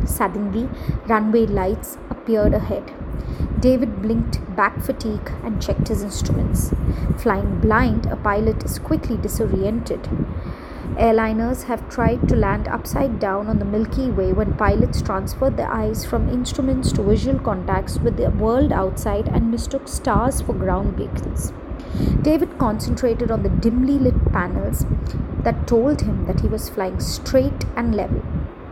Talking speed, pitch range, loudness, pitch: 140 wpm, 220-260 Hz, -21 LUFS, 230 Hz